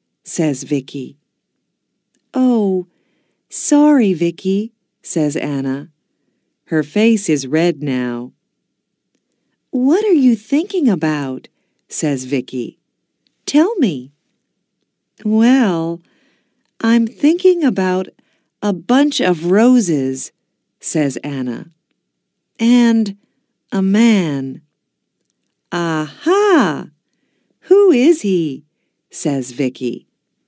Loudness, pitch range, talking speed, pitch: -16 LUFS, 150-250 Hz, 80 wpm, 185 Hz